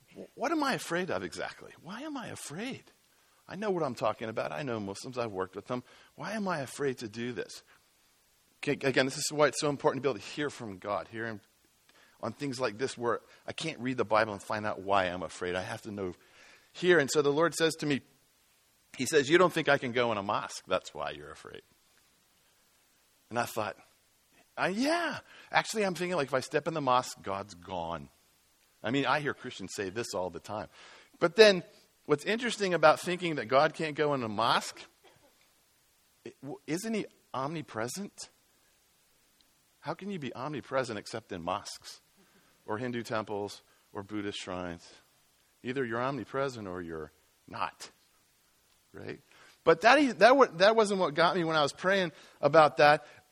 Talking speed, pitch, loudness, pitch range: 190 wpm, 135 Hz, -30 LUFS, 110-165 Hz